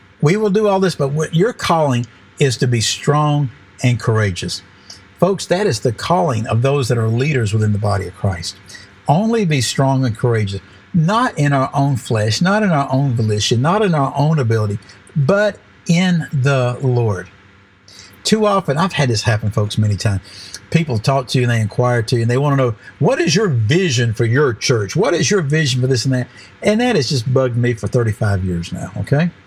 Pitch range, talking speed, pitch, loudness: 105-150 Hz, 210 wpm, 125 Hz, -16 LUFS